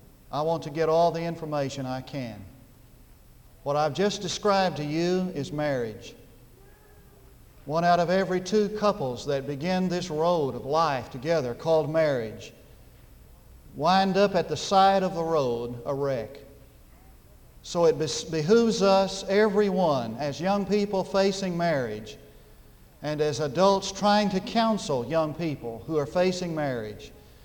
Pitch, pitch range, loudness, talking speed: 165 Hz, 140-190 Hz, -26 LUFS, 140 wpm